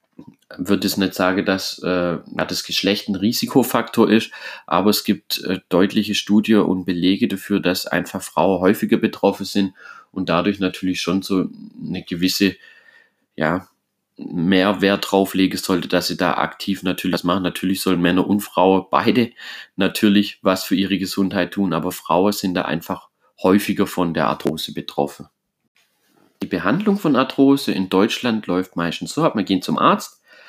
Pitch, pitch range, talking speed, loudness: 95 Hz, 90-100 Hz, 155 wpm, -19 LUFS